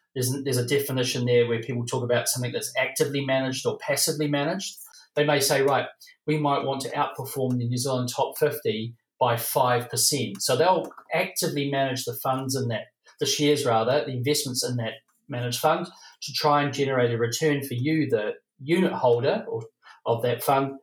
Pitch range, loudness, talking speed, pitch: 125-150 Hz, -25 LUFS, 185 wpm, 135 Hz